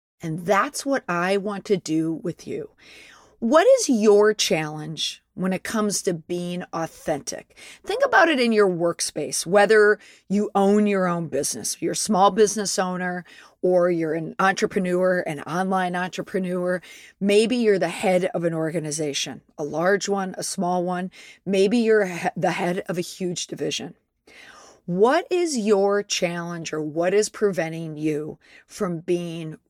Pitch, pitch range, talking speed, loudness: 185 Hz, 170-205 Hz, 150 wpm, -22 LUFS